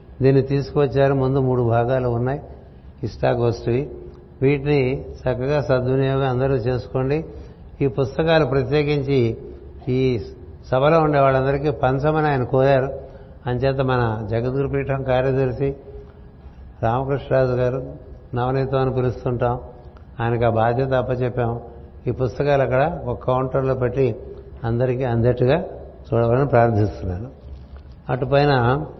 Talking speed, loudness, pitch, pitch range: 95 wpm, -20 LUFS, 130 Hz, 120-135 Hz